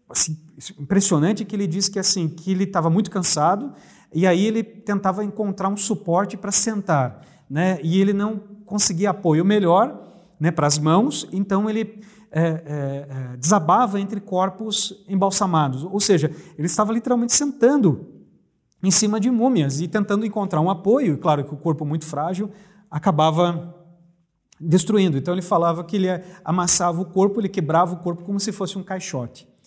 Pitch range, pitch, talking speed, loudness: 165-205 Hz, 190 Hz, 165 wpm, -20 LUFS